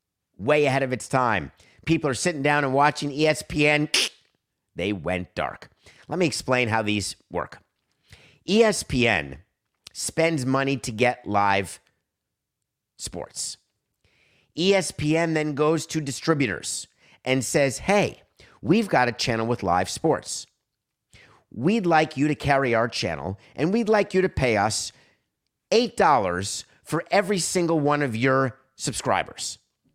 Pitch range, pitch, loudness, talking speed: 115-155 Hz, 140 Hz, -23 LUFS, 130 wpm